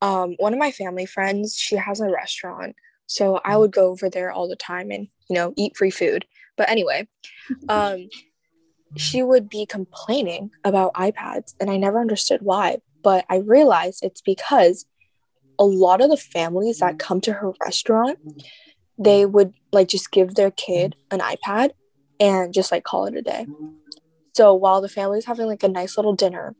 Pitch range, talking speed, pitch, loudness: 180-210 Hz, 180 wpm, 195 Hz, -20 LUFS